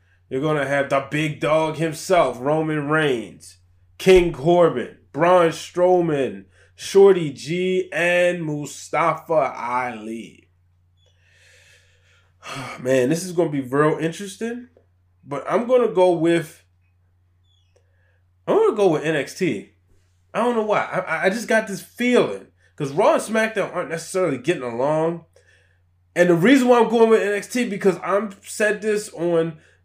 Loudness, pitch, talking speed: -20 LUFS, 155 Hz, 135 wpm